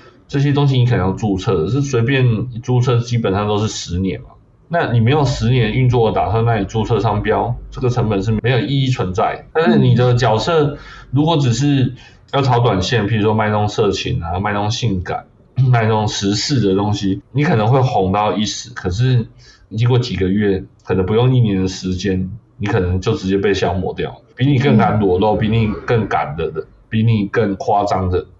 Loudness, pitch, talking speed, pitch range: -16 LUFS, 115 Hz, 300 characters per minute, 100-125 Hz